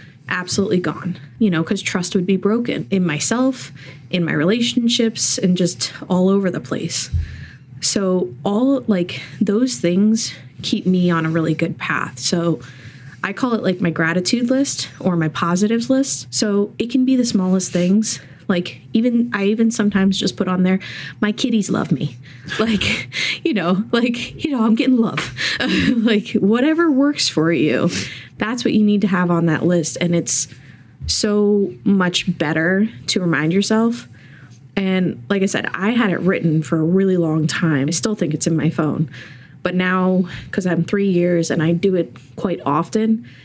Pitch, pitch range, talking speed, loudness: 185 Hz, 160-215 Hz, 175 wpm, -18 LUFS